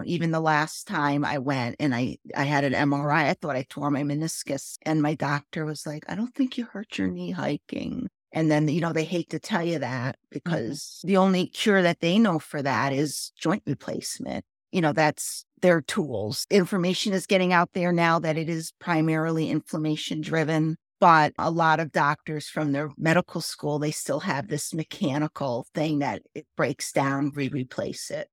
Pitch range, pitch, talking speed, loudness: 145-170 Hz, 155 Hz, 195 wpm, -26 LUFS